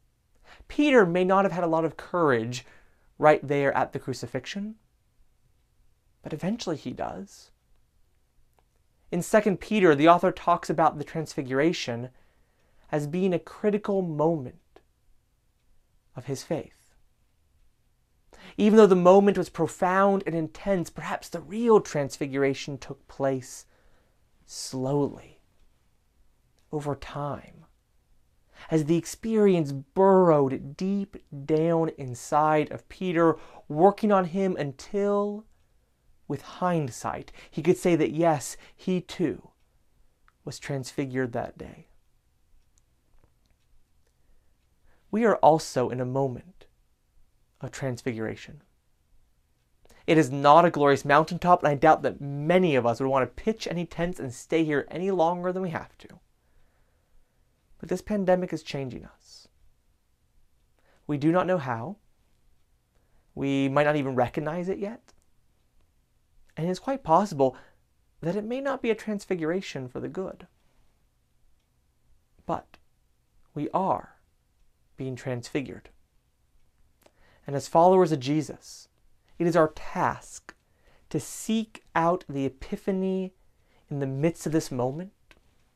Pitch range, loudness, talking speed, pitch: 130-180 Hz, -26 LUFS, 120 wpm, 155 Hz